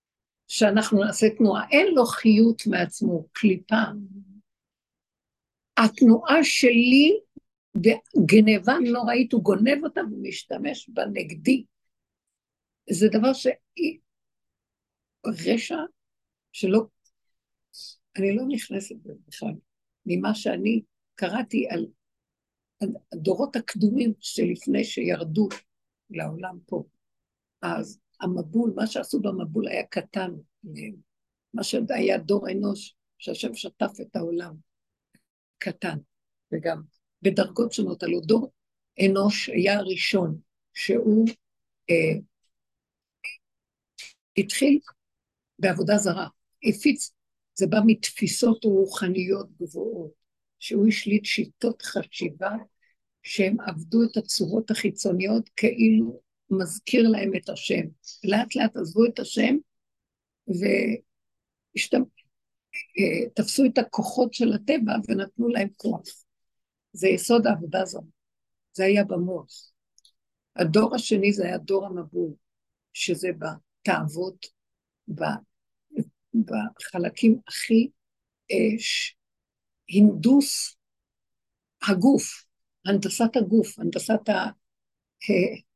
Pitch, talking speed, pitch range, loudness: 215 Hz, 90 wpm, 190-235 Hz, -24 LUFS